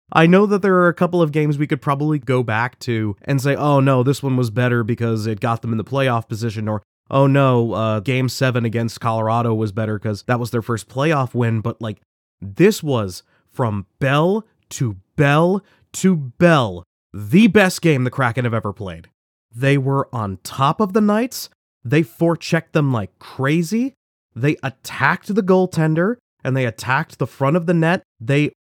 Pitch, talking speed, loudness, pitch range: 130 Hz, 190 wpm, -18 LUFS, 115-160 Hz